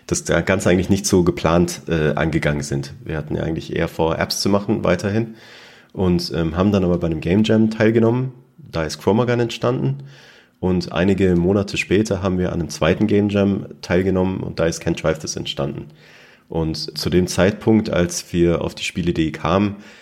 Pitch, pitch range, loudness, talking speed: 90 Hz, 80-105 Hz, -19 LUFS, 180 wpm